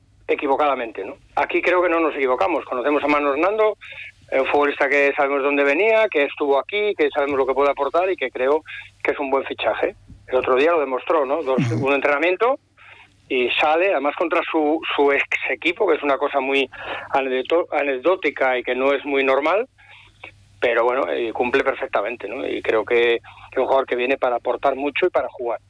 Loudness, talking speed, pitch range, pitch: -20 LUFS, 195 wpm, 130-165 Hz, 140 Hz